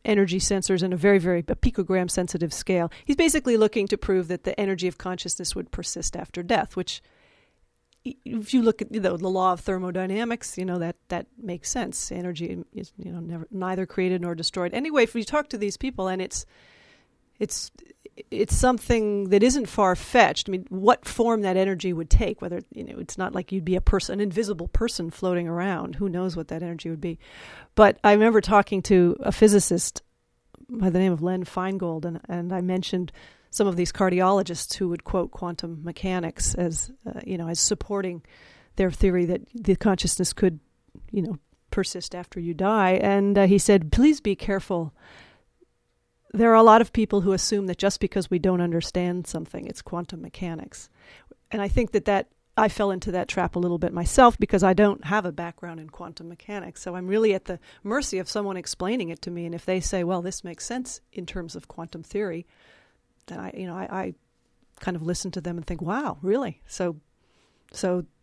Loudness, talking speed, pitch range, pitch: -24 LUFS, 200 wpm, 175-205 Hz, 185 Hz